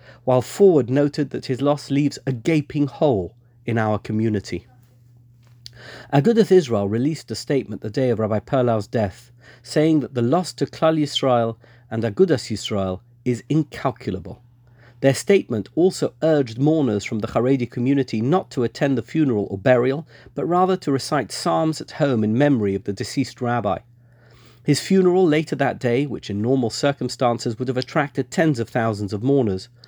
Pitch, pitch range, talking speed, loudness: 125 Hz, 115-145 Hz, 165 wpm, -21 LUFS